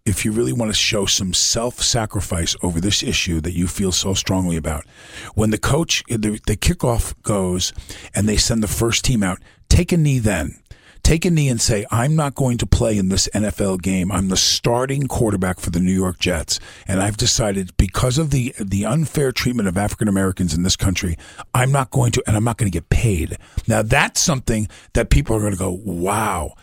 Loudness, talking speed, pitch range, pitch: -19 LUFS, 215 wpm, 95-120 Hz, 105 Hz